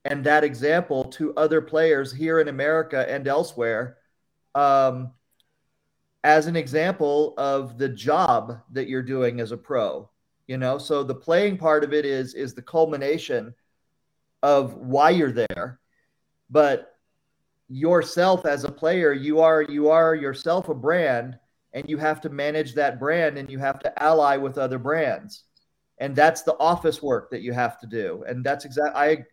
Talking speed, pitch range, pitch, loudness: 165 wpm, 130-155 Hz, 145 Hz, -22 LUFS